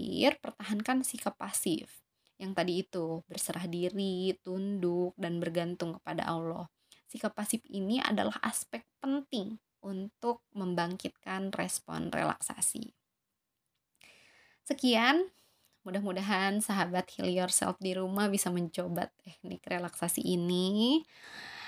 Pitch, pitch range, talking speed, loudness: 190 Hz, 180-225 Hz, 95 wpm, -33 LUFS